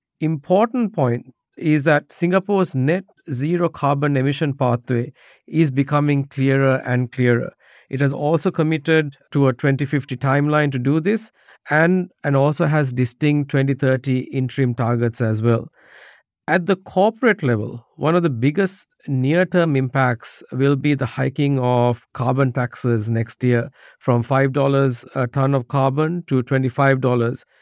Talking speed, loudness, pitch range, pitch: 140 wpm, -19 LUFS, 130-155 Hz, 140 Hz